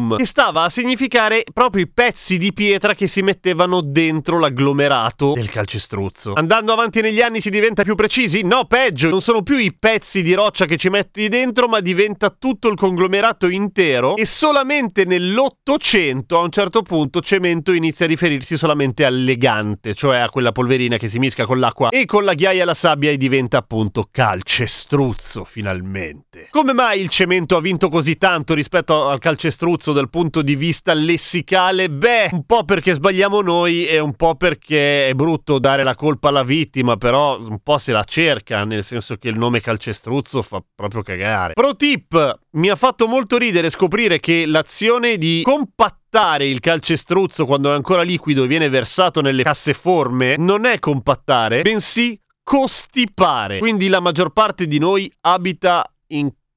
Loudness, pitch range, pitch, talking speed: -16 LUFS, 140-200 Hz, 170 Hz, 175 wpm